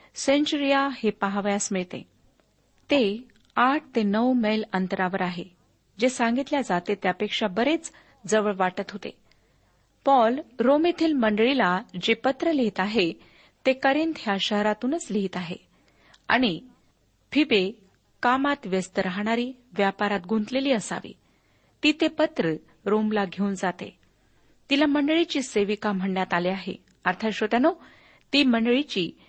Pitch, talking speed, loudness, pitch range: 220 Hz, 115 wpm, -25 LUFS, 195-270 Hz